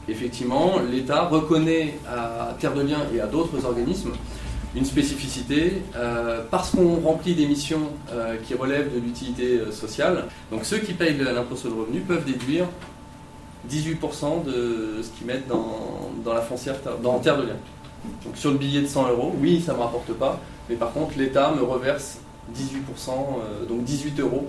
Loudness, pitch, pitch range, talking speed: -25 LUFS, 135 Hz, 120-150 Hz, 175 wpm